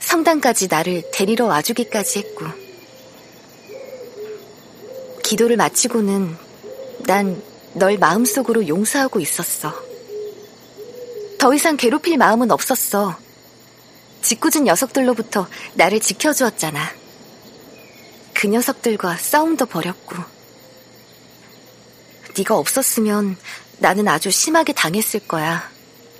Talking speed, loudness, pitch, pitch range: 220 characters per minute, -17 LUFS, 235 Hz, 200-310 Hz